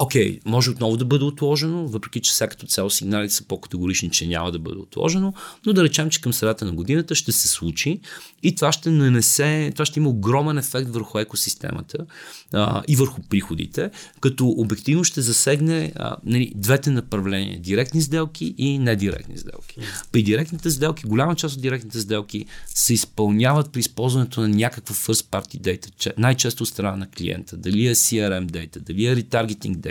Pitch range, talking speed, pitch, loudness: 105-145 Hz, 180 wpm, 120 Hz, -21 LUFS